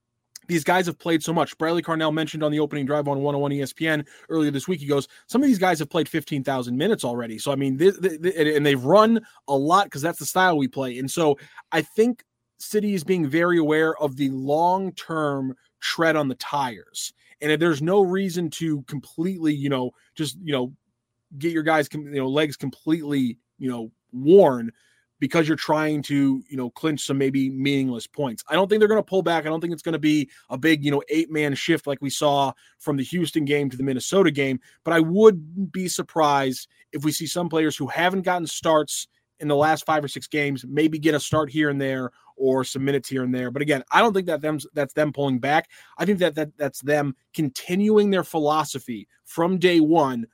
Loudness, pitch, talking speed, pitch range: -23 LUFS, 150 Hz, 220 wpm, 140-165 Hz